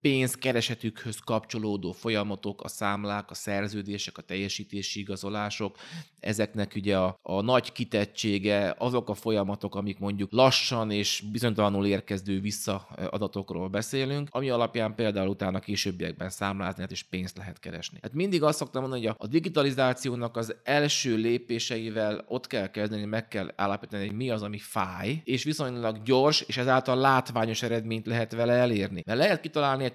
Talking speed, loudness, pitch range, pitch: 150 wpm, -29 LUFS, 100-125 Hz, 110 Hz